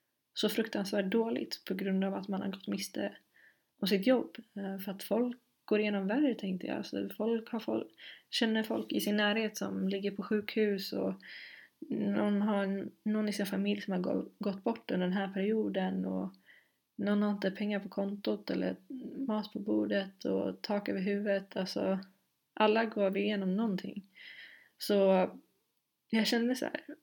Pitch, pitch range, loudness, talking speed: 205 Hz, 195-220 Hz, -34 LUFS, 165 wpm